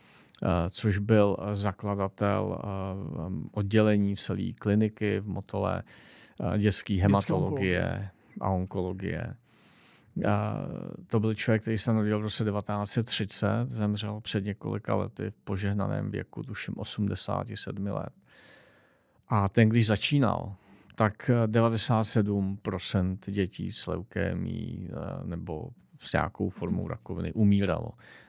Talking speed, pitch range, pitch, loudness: 110 wpm, 100-110 Hz, 105 Hz, -28 LUFS